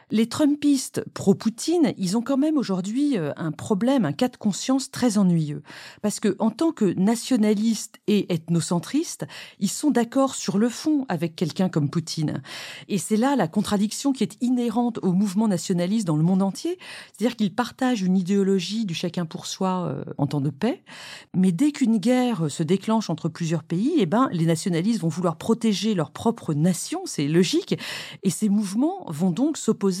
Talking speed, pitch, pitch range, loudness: 180 wpm, 210 Hz, 180-245 Hz, -24 LUFS